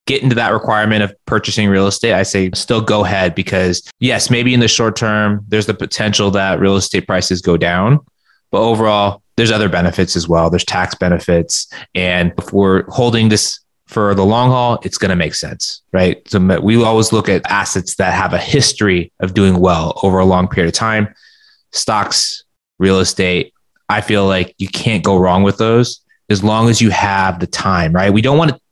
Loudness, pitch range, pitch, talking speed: -13 LUFS, 95-110 Hz, 100 Hz, 205 wpm